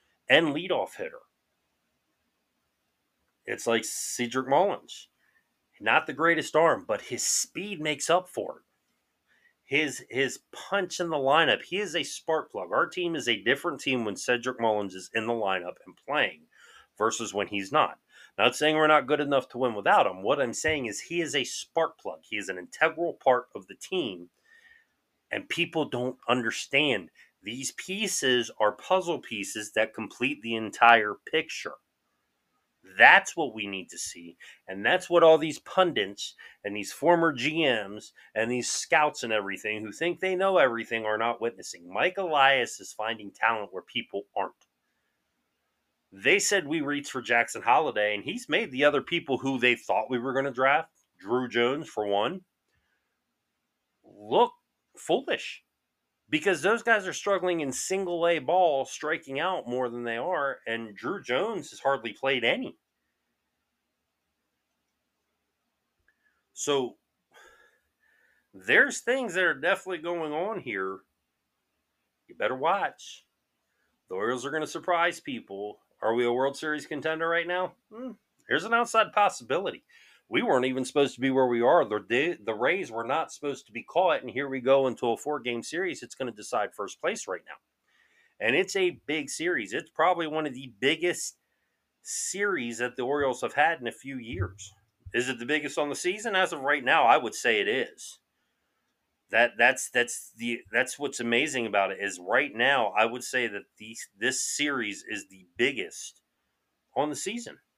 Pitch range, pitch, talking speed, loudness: 115-175 Hz, 135 Hz, 170 wpm, -27 LUFS